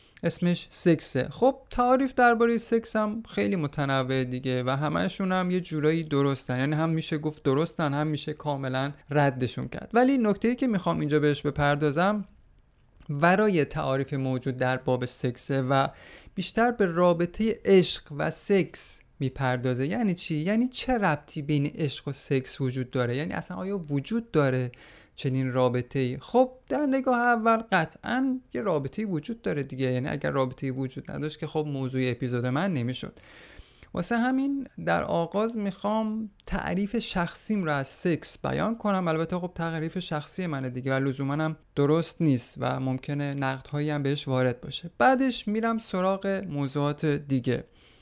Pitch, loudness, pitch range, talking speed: 155 Hz, -27 LUFS, 135-200 Hz, 150 wpm